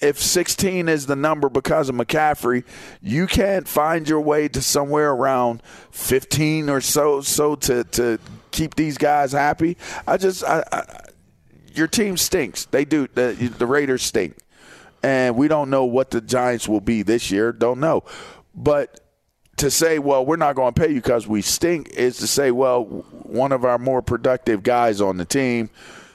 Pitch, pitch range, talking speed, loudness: 140 Hz, 125-155 Hz, 180 wpm, -20 LUFS